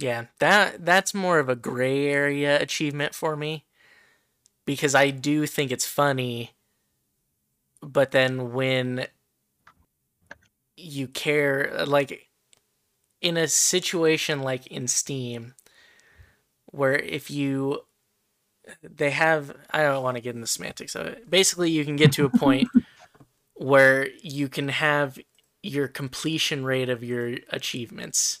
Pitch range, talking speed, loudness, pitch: 130-155 Hz, 130 wpm, -24 LUFS, 145 Hz